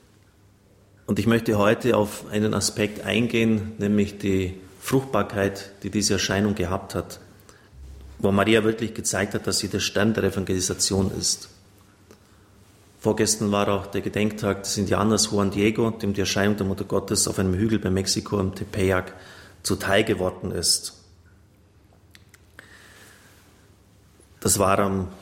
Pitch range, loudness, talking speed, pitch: 95-105 Hz, -23 LUFS, 135 wpm, 100 Hz